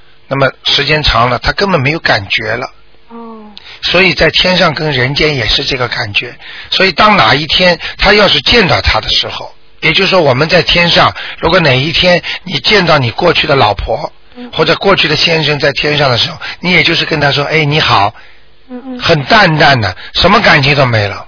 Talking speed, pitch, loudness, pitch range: 290 characters per minute, 155 Hz, -9 LUFS, 140-180 Hz